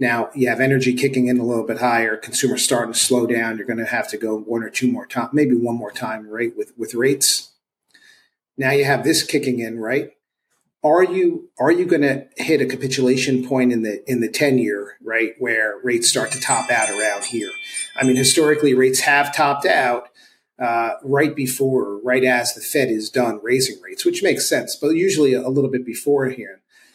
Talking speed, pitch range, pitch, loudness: 210 wpm, 115-145 Hz, 130 Hz, -19 LUFS